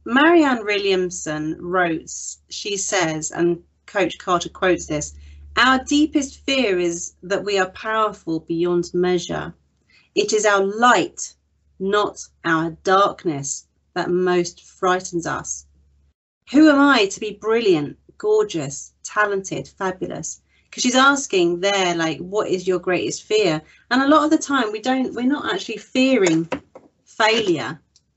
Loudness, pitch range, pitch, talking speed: -20 LUFS, 170-250 Hz, 195 Hz, 135 wpm